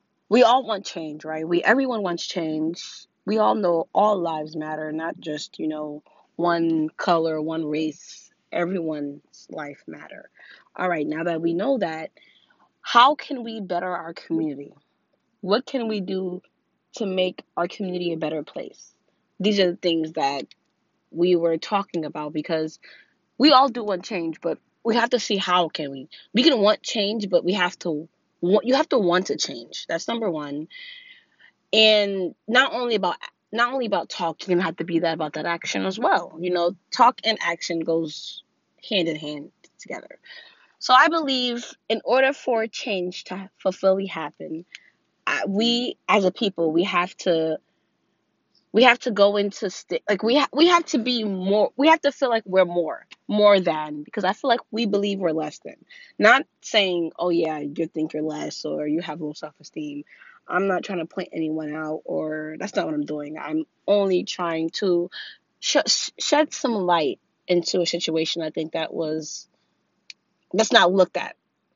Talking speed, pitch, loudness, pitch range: 180 wpm, 180 Hz, -23 LUFS, 160-220 Hz